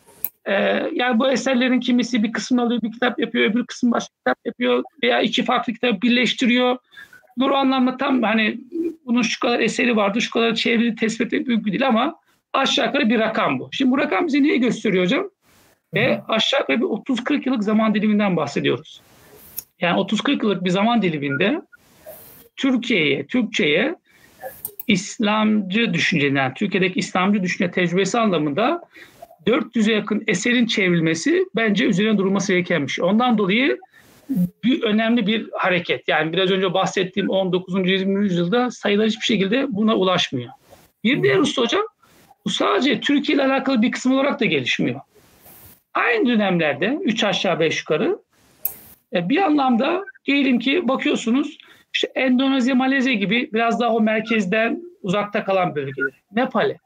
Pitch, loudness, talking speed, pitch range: 230 Hz, -20 LUFS, 145 wpm, 205-265 Hz